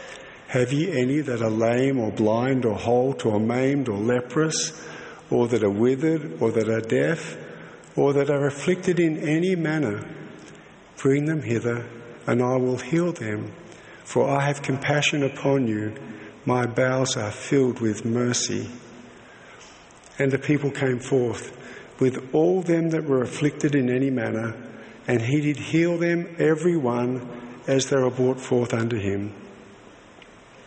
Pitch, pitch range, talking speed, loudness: 130 Hz, 120-145 Hz, 150 wpm, -23 LUFS